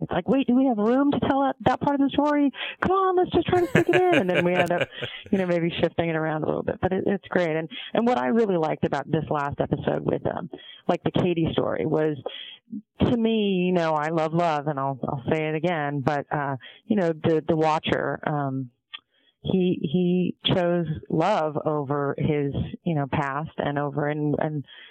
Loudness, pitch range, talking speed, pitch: -24 LUFS, 150-210 Hz, 220 wpm, 170 Hz